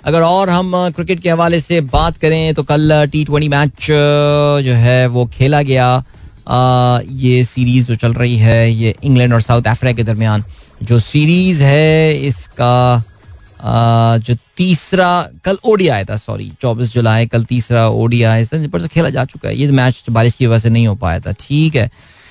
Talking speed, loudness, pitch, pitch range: 180 wpm, -12 LUFS, 125 Hz, 115-150 Hz